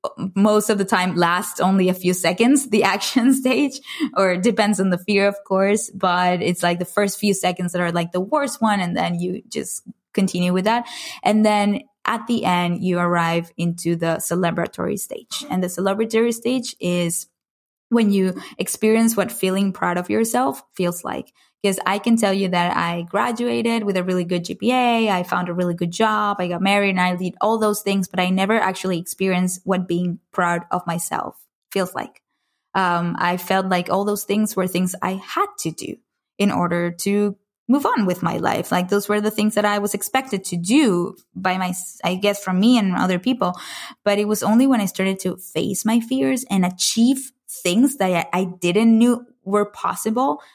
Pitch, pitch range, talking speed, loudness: 195 Hz, 180-220 Hz, 200 wpm, -20 LUFS